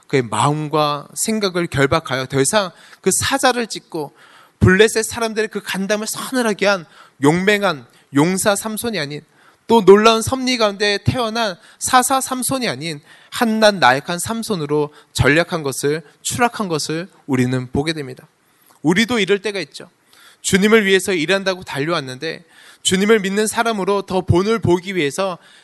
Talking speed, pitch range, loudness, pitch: 315 characters per minute, 155-220 Hz, -17 LUFS, 195 Hz